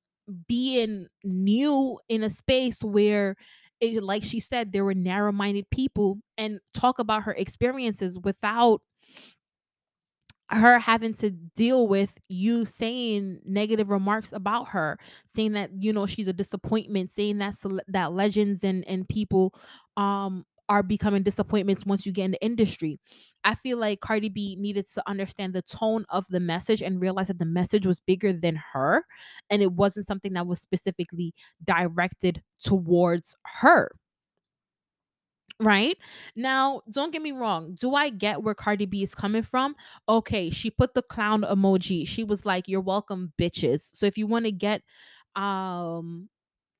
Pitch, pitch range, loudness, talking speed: 205 Hz, 190-220 Hz, -26 LUFS, 155 wpm